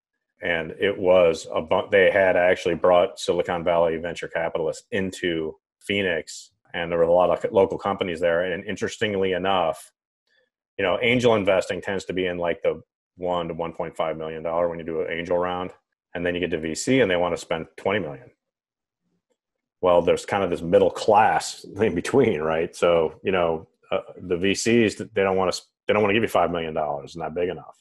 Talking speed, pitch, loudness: 205 wpm, 95 Hz, -23 LUFS